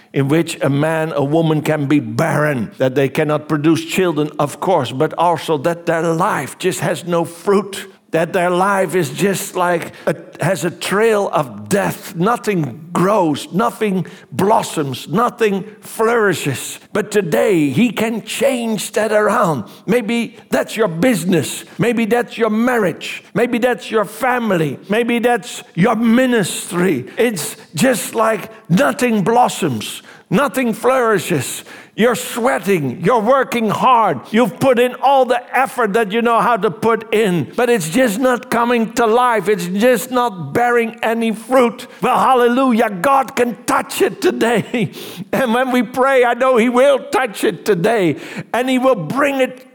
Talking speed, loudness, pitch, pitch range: 155 wpm, -16 LUFS, 215 Hz, 170-240 Hz